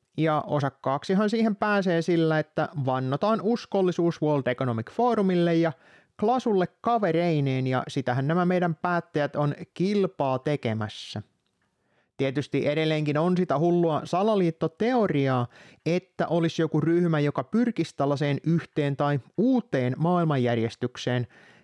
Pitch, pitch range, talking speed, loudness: 160 Hz, 140-180 Hz, 110 wpm, -26 LUFS